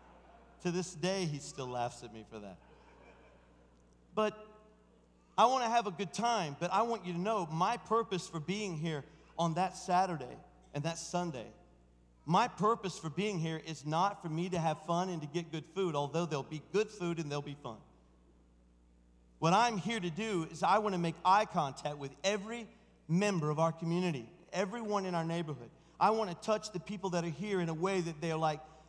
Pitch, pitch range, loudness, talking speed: 170 Hz, 150-195 Hz, -35 LUFS, 205 wpm